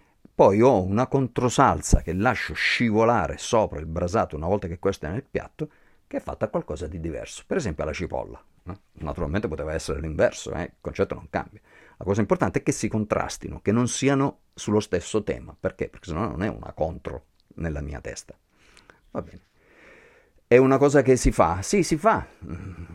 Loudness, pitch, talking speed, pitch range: -24 LUFS, 110 Hz, 190 wpm, 85-135 Hz